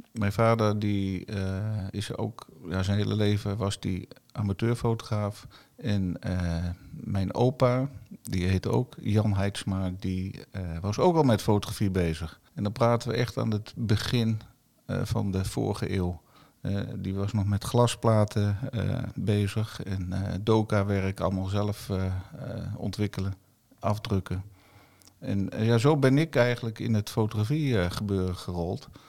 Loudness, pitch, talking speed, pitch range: -28 LUFS, 105 Hz, 145 wpm, 95-115 Hz